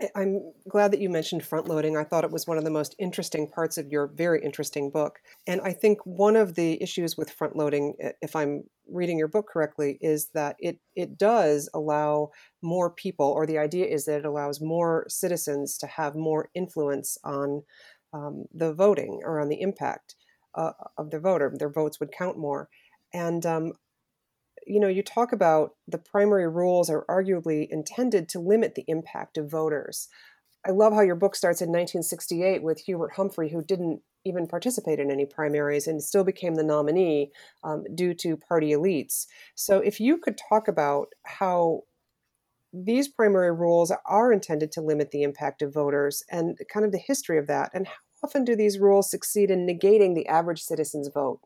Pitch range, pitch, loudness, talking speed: 150-195 Hz, 165 Hz, -26 LUFS, 190 wpm